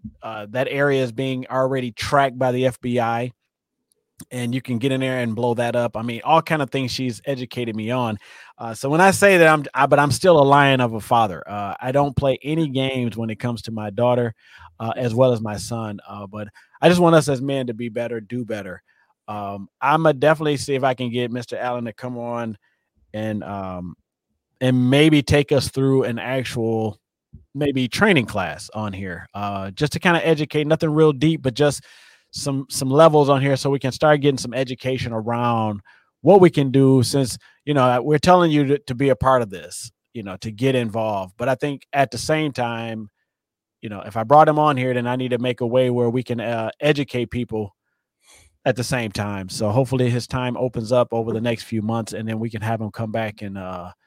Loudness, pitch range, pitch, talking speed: -20 LUFS, 115-140 Hz, 125 Hz, 225 wpm